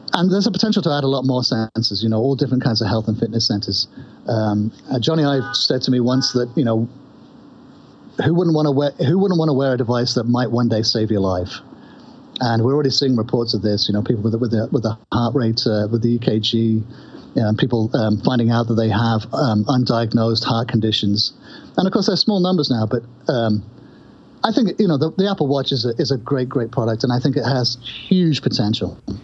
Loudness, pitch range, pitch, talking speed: -18 LUFS, 110-145 Hz, 125 Hz, 230 wpm